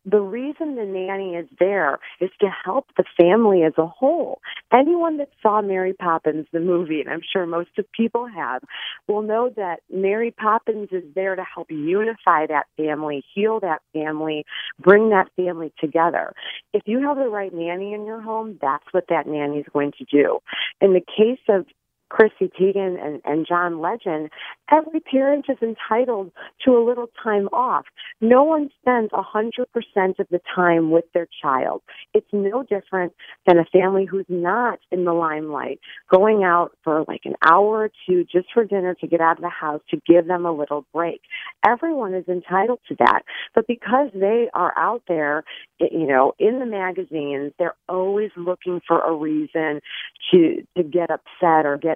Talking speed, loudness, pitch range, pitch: 180 wpm, -21 LUFS, 165-220 Hz, 185 Hz